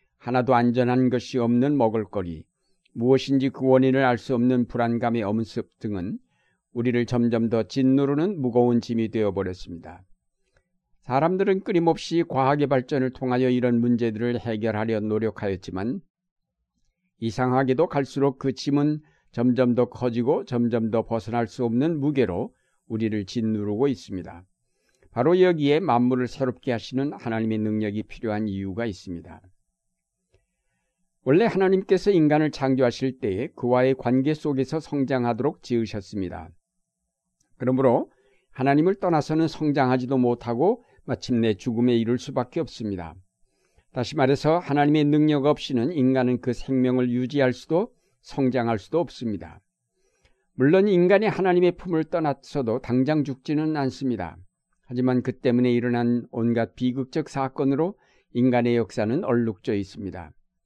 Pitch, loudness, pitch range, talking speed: 125 Hz, -24 LUFS, 115-145 Hz, 315 characters per minute